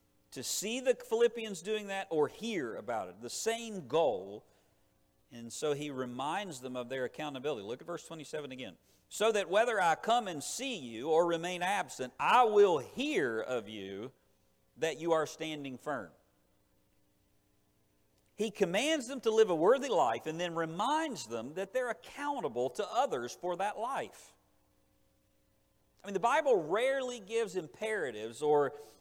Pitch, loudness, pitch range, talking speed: 190 Hz, -33 LUFS, 150-235 Hz, 155 wpm